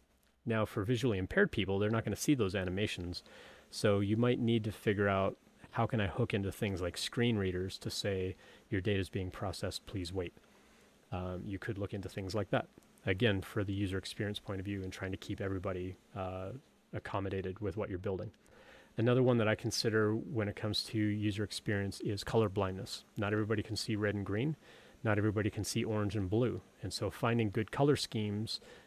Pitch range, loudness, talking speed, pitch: 95-110 Hz, -35 LUFS, 205 wpm, 105 Hz